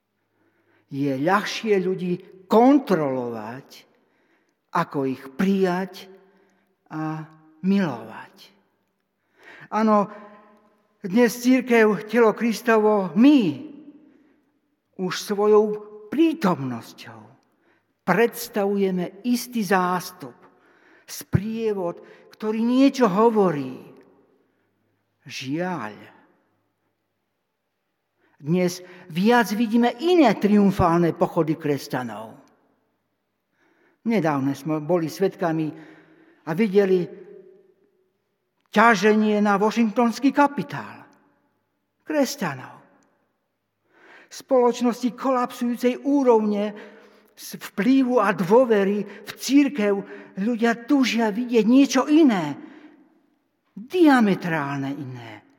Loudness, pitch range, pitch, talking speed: -21 LUFS, 180-245 Hz, 210 Hz, 65 wpm